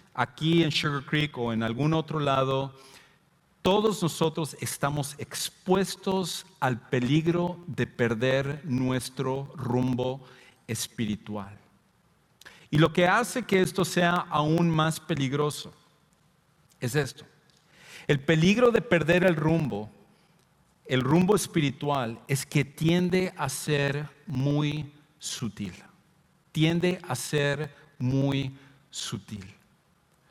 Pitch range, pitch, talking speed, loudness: 130-170 Hz, 150 Hz, 105 wpm, -27 LUFS